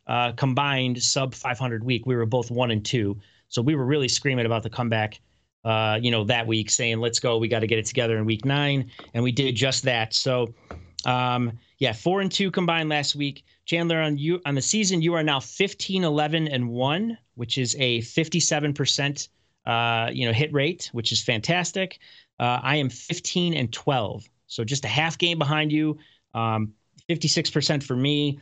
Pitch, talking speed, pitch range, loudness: 130 Hz, 195 wpm, 115-150 Hz, -24 LUFS